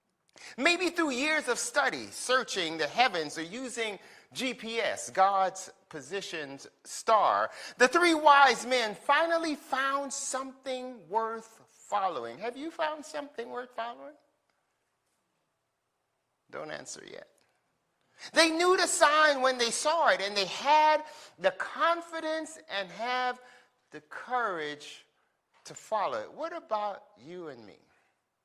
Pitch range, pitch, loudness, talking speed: 215-305 Hz, 255 Hz, -28 LUFS, 120 wpm